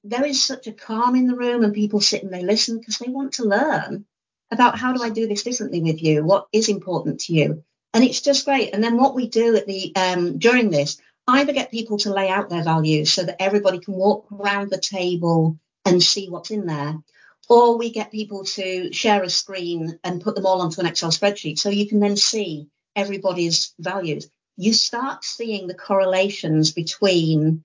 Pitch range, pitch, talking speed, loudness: 175-225 Hz, 200 Hz, 210 wpm, -20 LUFS